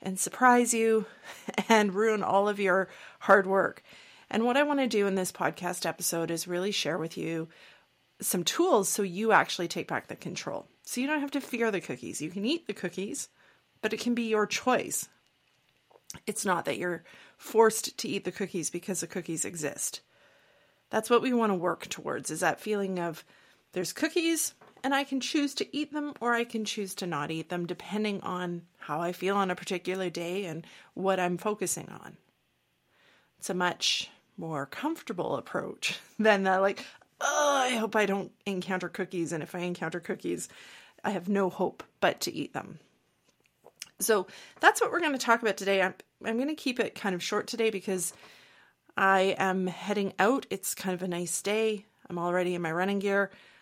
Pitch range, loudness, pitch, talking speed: 180-225 Hz, -29 LUFS, 195 Hz, 195 wpm